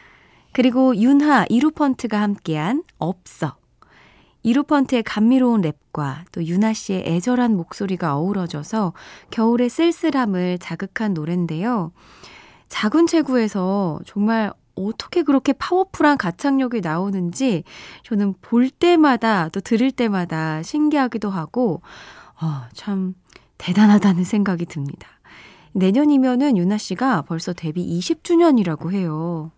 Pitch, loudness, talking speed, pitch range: 210 Hz, -20 LUFS, 275 characters per minute, 175-260 Hz